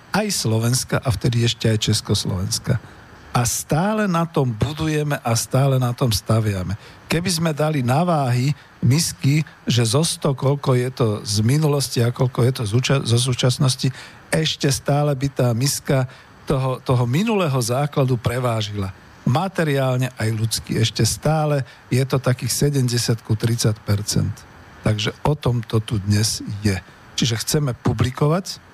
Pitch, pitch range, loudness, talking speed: 125 Hz, 115-145 Hz, -20 LUFS, 140 wpm